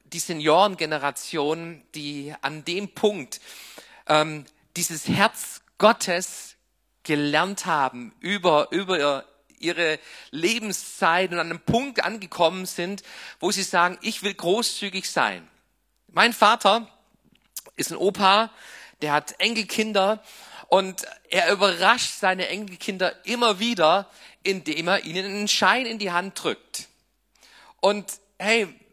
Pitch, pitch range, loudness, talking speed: 185 Hz, 165-205 Hz, -23 LUFS, 115 wpm